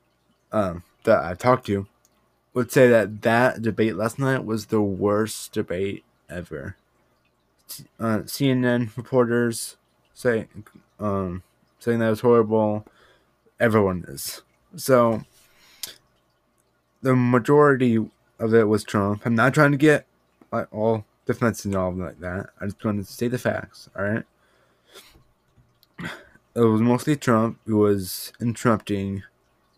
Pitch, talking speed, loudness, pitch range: 110 Hz, 125 wpm, -22 LUFS, 95-120 Hz